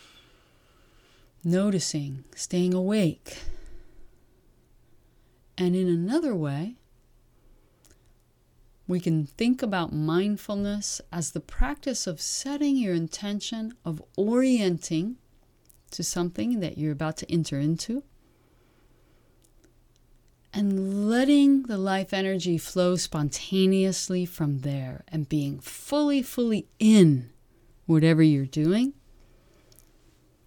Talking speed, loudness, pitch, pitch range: 90 wpm, -26 LUFS, 180 Hz, 155-210 Hz